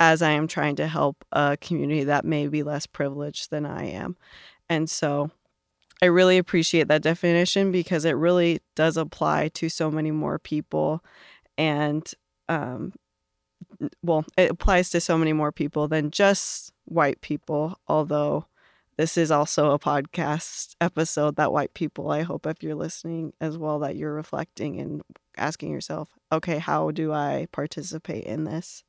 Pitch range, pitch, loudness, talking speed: 150-165 Hz, 155 Hz, -25 LUFS, 160 wpm